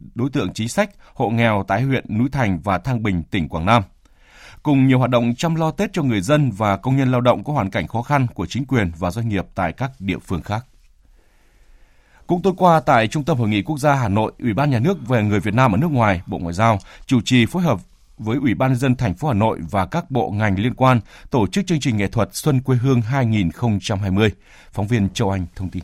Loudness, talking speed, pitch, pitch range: -19 LUFS, 250 wpm, 120 Hz, 100-135 Hz